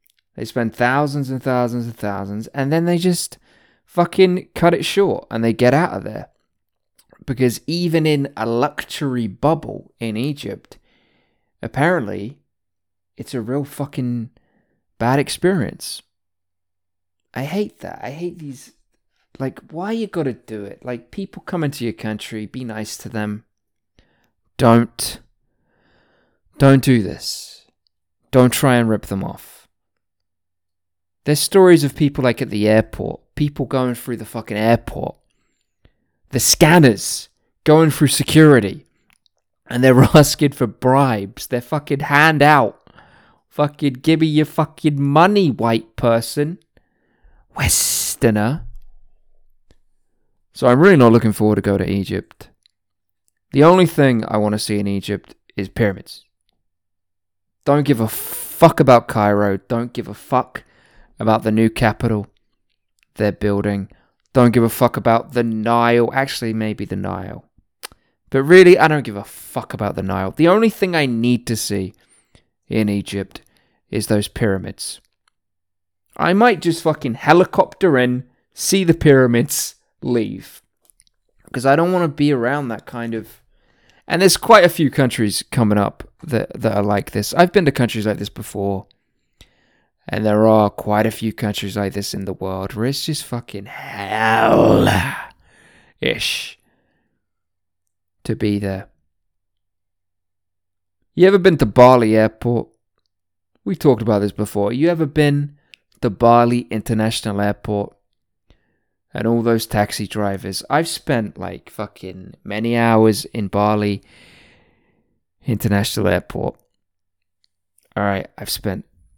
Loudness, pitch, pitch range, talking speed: -17 LUFS, 115 Hz, 100-140 Hz, 135 wpm